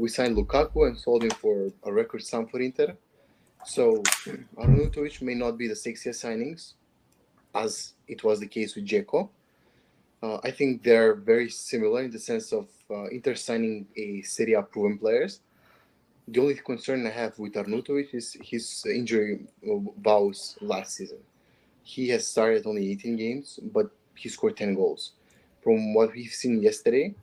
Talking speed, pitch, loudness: 165 wpm, 120 Hz, -27 LUFS